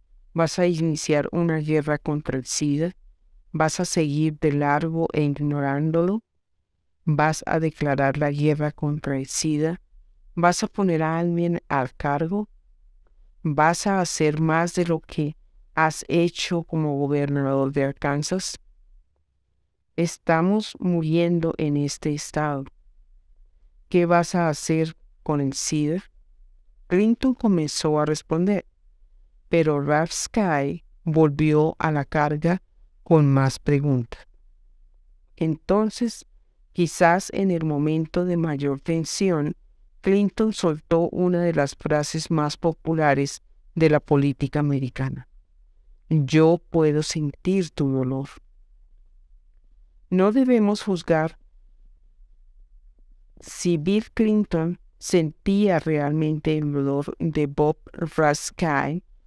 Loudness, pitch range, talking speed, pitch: -23 LUFS, 140-170 Hz, 105 wpm, 155 Hz